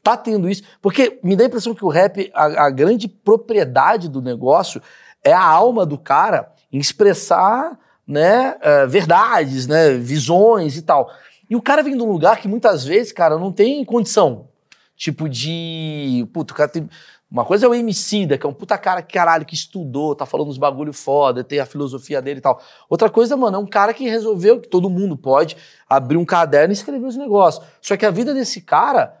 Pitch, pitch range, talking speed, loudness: 185 Hz, 150-220 Hz, 200 wpm, -16 LUFS